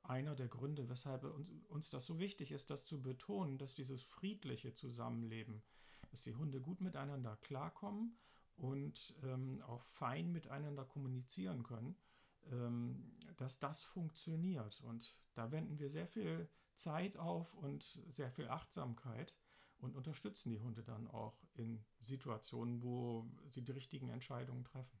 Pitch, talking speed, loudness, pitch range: 135 Hz, 140 wpm, -49 LUFS, 120-155 Hz